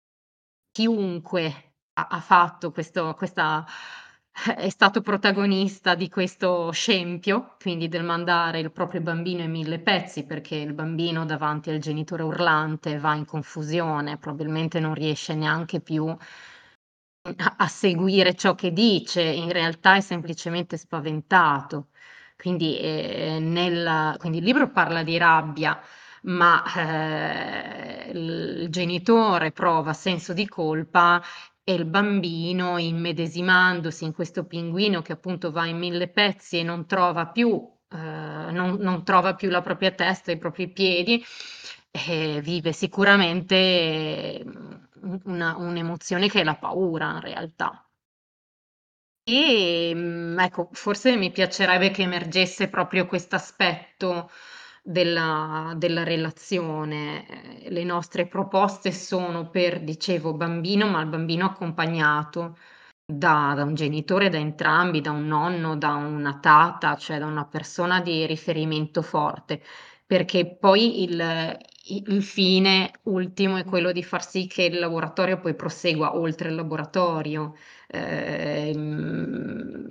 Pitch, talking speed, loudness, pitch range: 175 Hz, 125 wpm, -24 LUFS, 160-185 Hz